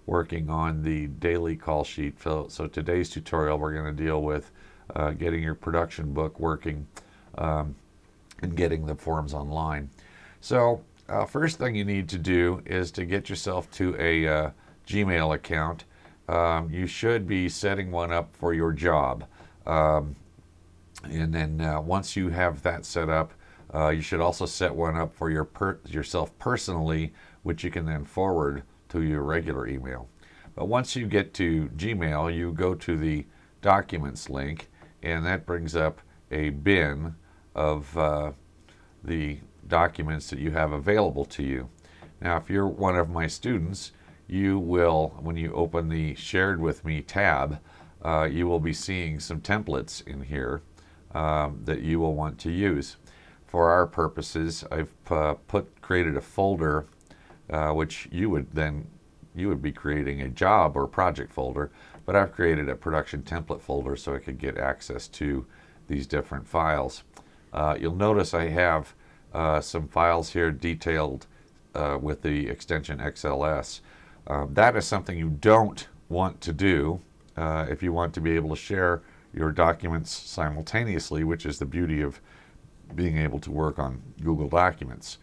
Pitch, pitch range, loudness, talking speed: 80 Hz, 75-85 Hz, -27 LUFS, 165 wpm